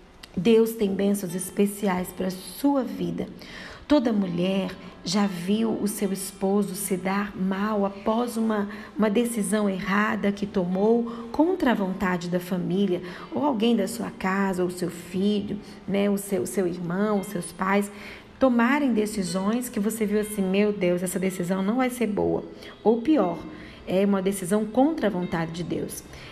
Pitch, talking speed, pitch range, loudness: 200 Hz, 160 wpm, 190-215 Hz, -25 LUFS